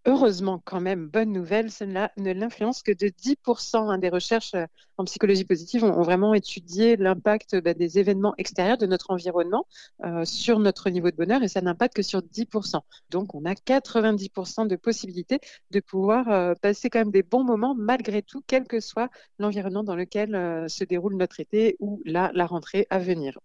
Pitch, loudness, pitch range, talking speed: 200 Hz, -25 LUFS, 185-225 Hz, 190 wpm